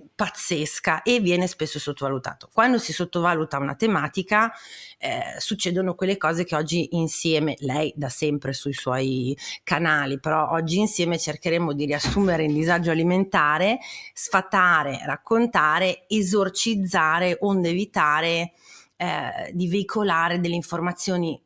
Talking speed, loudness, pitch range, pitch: 115 wpm, -23 LUFS, 155-200 Hz, 175 Hz